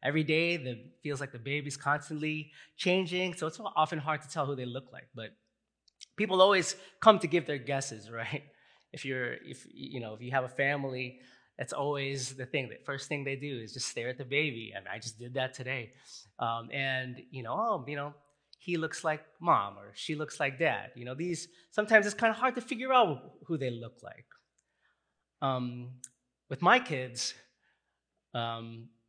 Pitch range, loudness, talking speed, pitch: 125-160 Hz, -32 LUFS, 205 wpm, 140 Hz